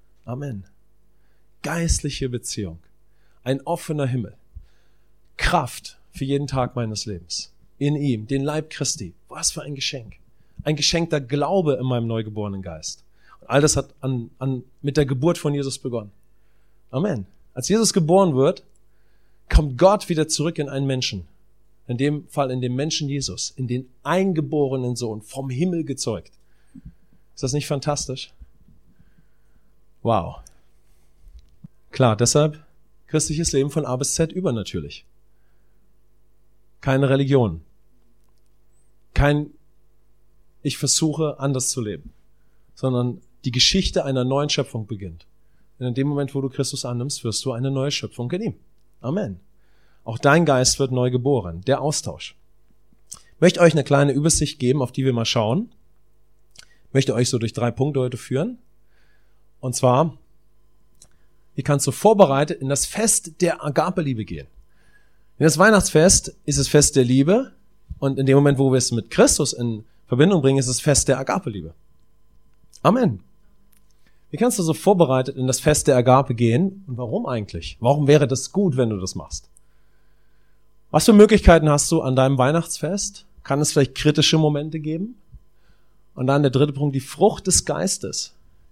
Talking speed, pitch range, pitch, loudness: 150 wpm, 110-150 Hz, 135 Hz, -20 LUFS